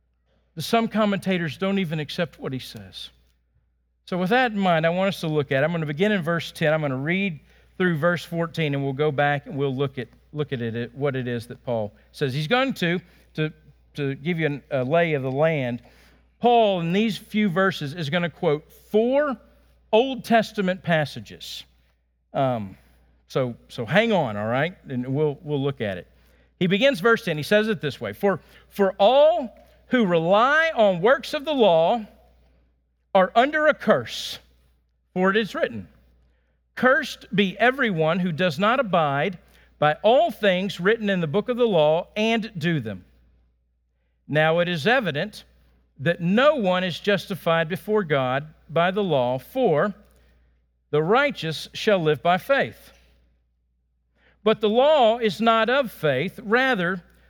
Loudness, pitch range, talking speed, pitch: -22 LUFS, 125-205 Hz, 175 wpm, 165 Hz